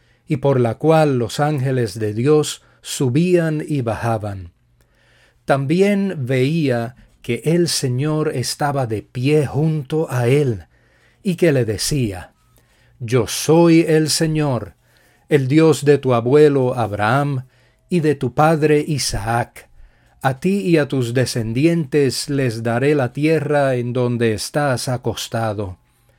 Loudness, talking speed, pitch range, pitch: -18 LUFS, 125 wpm, 120-150 Hz, 135 Hz